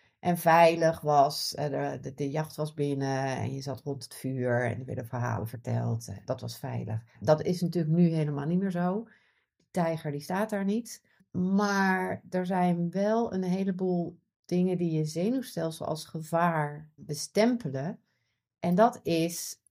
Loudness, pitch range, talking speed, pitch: -29 LUFS, 135-185 Hz, 155 wpm, 165 Hz